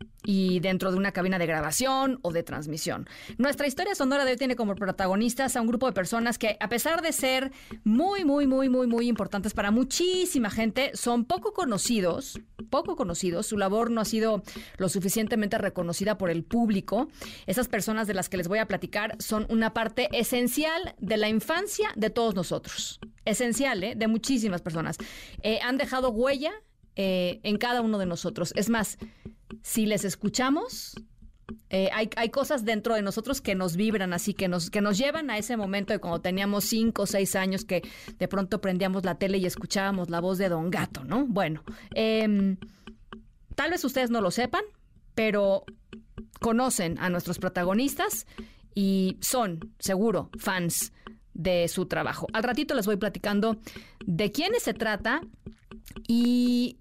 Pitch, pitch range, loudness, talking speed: 215 Hz, 190-245 Hz, -27 LUFS, 170 wpm